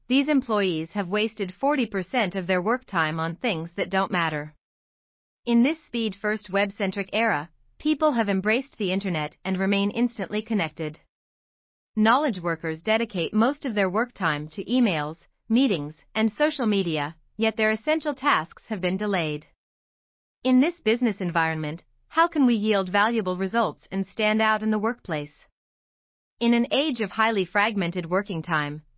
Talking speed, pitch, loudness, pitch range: 155 wpm, 205 Hz, -25 LUFS, 175-230 Hz